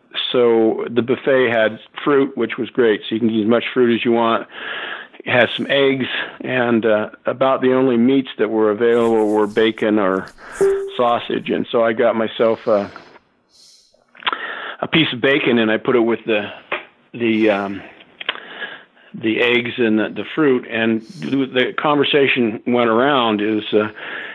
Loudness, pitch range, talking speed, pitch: -17 LUFS, 110-130 Hz, 165 wpm, 115 Hz